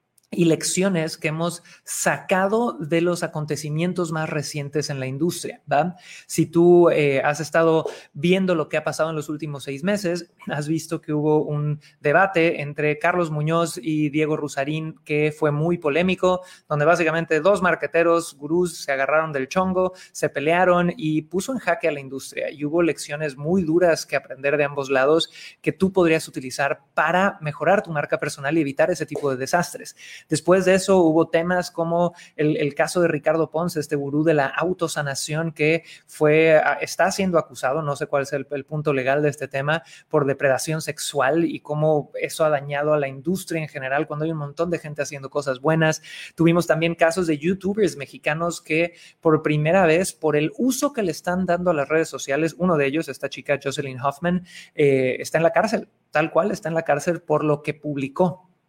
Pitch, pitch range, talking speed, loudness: 155 Hz, 150-170 Hz, 190 wpm, -22 LUFS